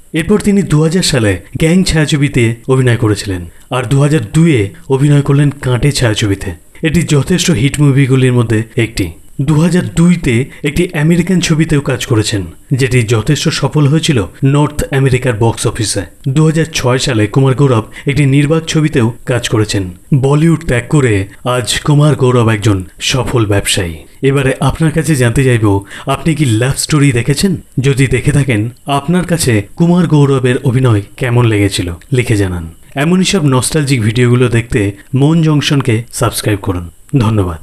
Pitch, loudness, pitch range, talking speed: 130 Hz, -12 LUFS, 110-150 Hz, 140 wpm